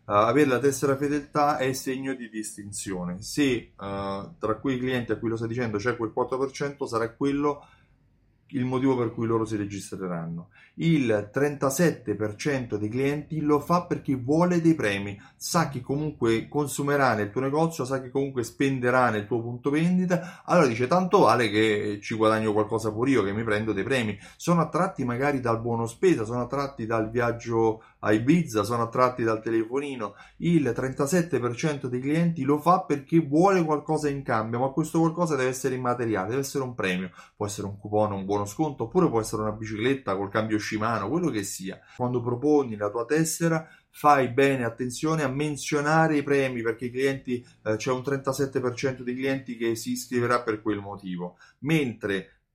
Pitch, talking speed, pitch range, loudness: 125 Hz, 175 wpm, 110-145 Hz, -26 LUFS